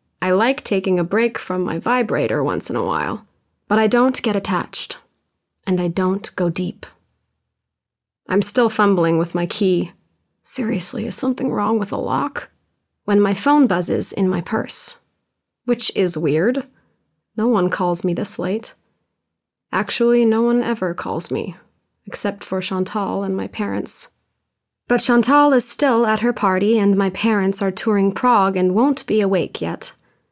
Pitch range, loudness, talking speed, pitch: 185-235 Hz, -19 LUFS, 160 wpm, 205 Hz